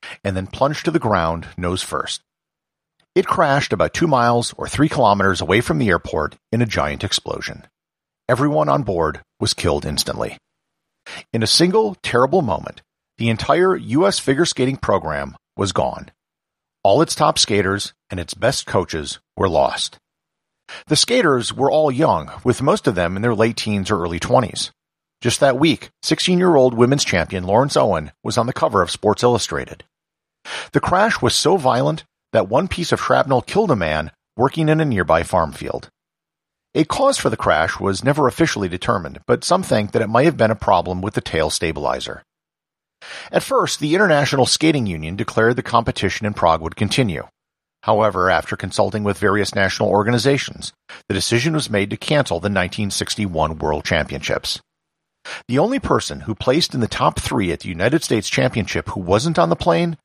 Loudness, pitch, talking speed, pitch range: -18 LUFS, 110 Hz, 175 wpm, 95-135 Hz